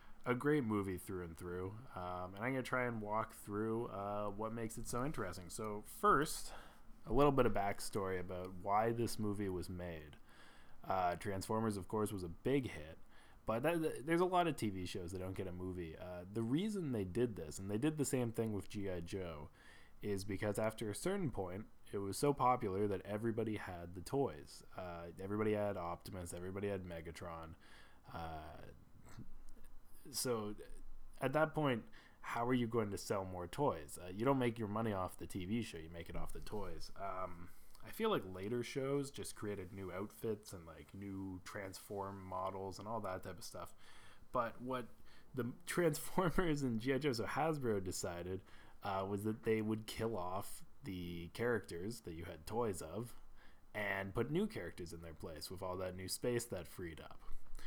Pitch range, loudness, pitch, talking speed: 90-115 Hz, -41 LUFS, 100 Hz, 190 wpm